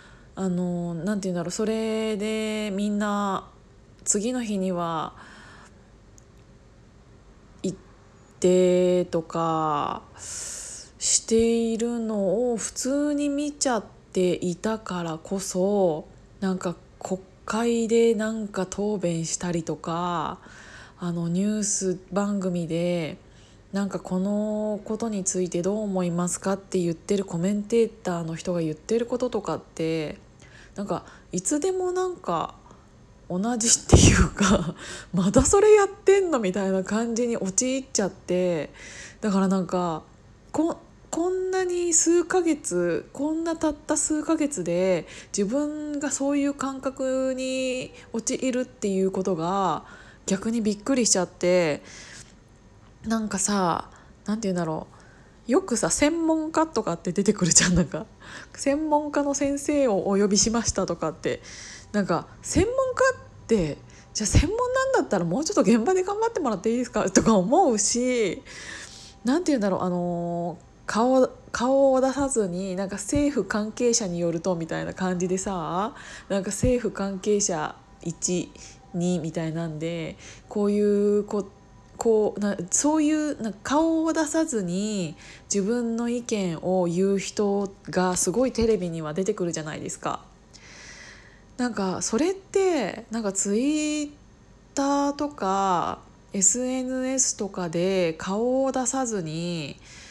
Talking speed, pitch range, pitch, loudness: 260 characters per minute, 180-255 Hz, 205 Hz, -25 LUFS